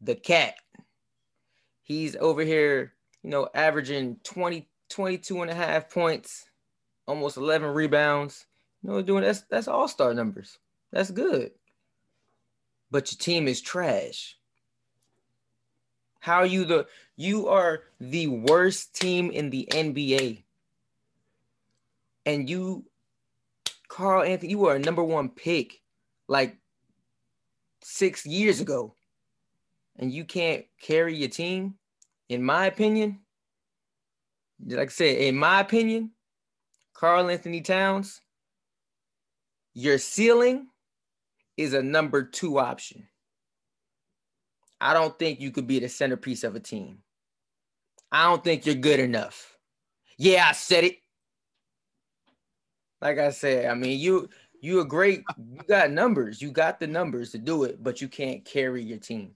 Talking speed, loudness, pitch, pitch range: 130 wpm, -25 LUFS, 155 Hz, 135-180 Hz